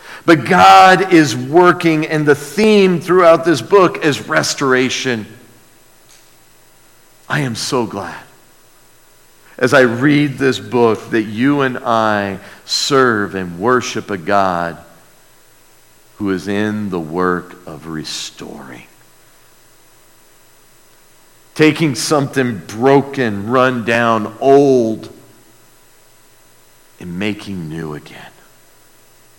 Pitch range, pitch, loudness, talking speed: 95-140 Hz, 120 Hz, -14 LUFS, 95 wpm